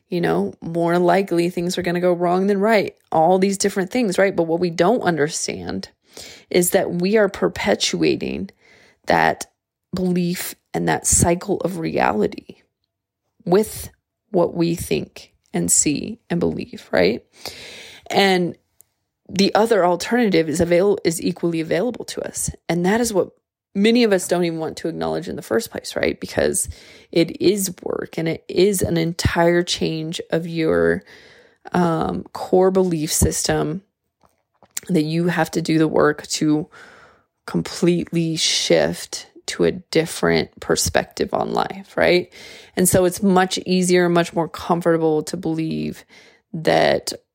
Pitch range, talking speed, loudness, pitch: 165-190 Hz, 145 wpm, -20 LUFS, 175 Hz